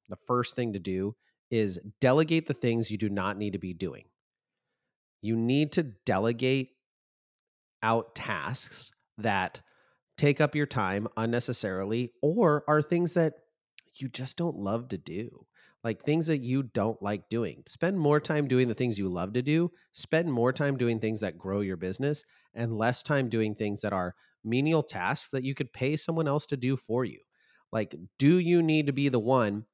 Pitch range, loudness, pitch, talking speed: 110-150 Hz, -29 LUFS, 125 Hz, 185 wpm